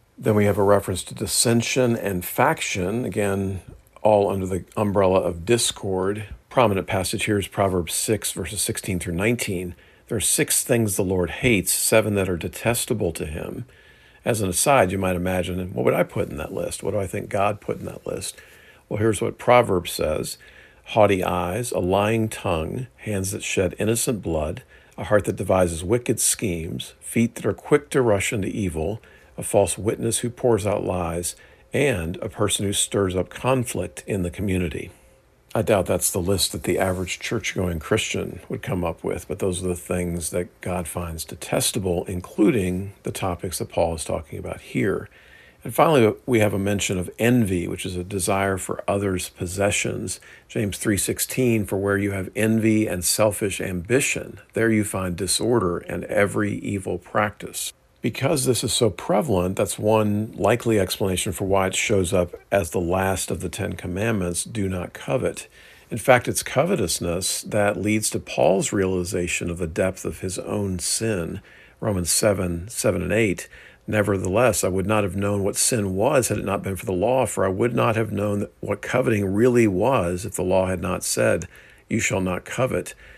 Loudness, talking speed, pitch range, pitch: -23 LUFS, 185 wpm, 90-110 Hz, 100 Hz